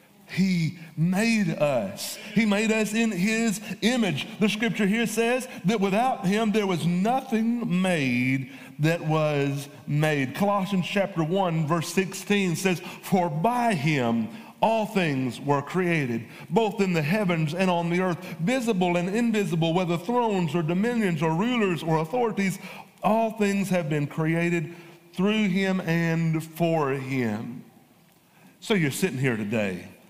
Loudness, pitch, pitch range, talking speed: -25 LUFS, 185 Hz, 160-210 Hz, 140 wpm